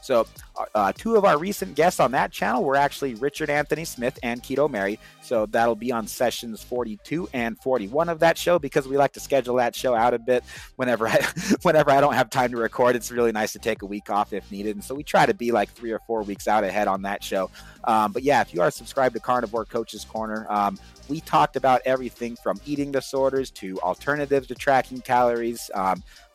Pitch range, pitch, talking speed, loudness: 110-140 Hz, 125 Hz, 225 wpm, -24 LUFS